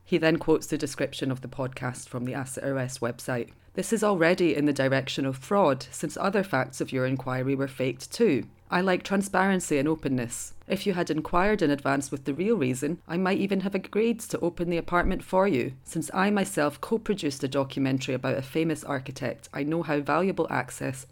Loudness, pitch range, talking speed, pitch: -27 LUFS, 135-180 Hz, 205 wpm, 145 Hz